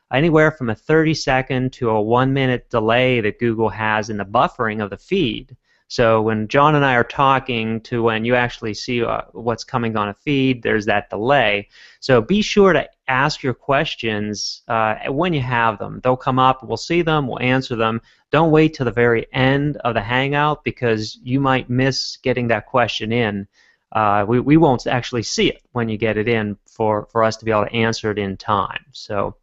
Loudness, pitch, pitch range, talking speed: -18 LUFS, 120 Hz, 110-130 Hz, 210 wpm